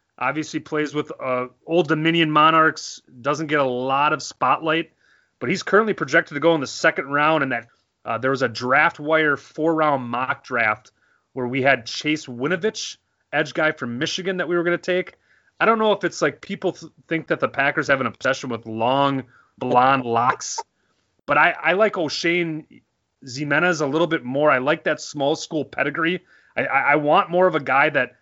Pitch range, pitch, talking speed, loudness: 135-165 Hz, 150 Hz, 200 wpm, -21 LUFS